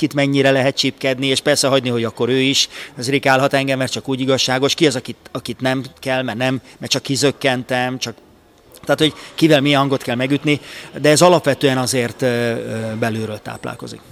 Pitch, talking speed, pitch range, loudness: 130 Hz, 180 wpm, 125-140 Hz, -17 LUFS